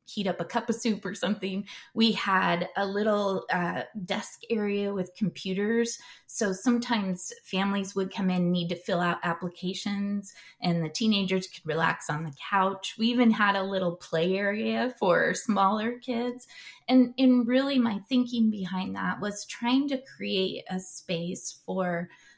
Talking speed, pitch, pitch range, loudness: 160 wpm, 200 Hz, 185-230 Hz, -28 LUFS